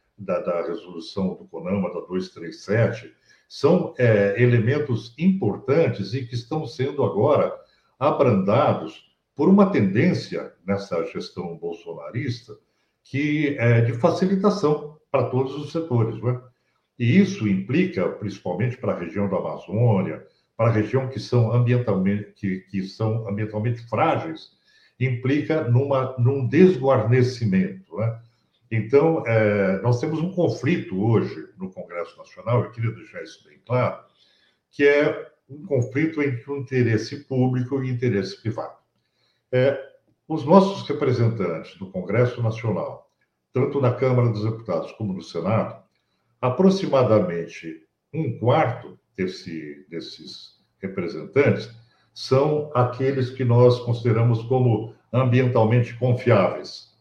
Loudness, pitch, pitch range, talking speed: -22 LUFS, 125 Hz, 110-140 Hz, 120 wpm